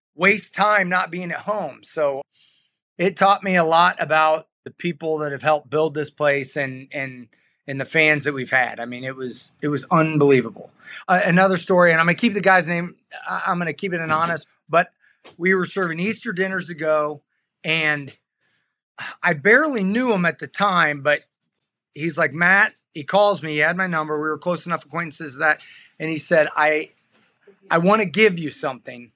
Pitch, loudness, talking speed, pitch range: 160 Hz, -20 LUFS, 195 wpm, 150-185 Hz